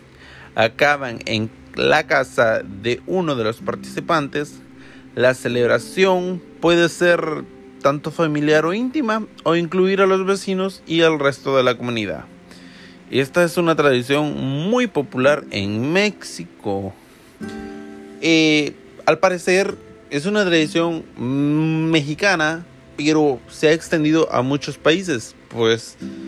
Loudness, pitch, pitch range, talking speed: -19 LUFS, 150 Hz, 115-170 Hz, 115 wpm